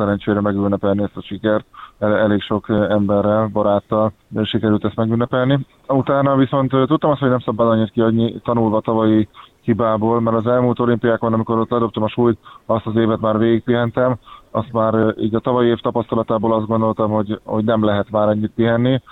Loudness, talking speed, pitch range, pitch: -18 LUFS, 175 wpm, 110-120 Hz, 115 Hz